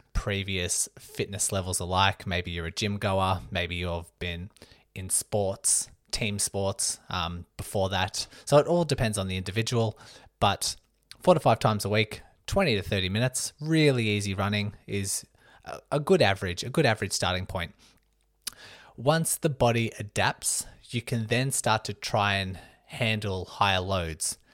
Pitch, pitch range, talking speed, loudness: 100 Hz, 95-115 Hz, 155 wpm, -27 LUFS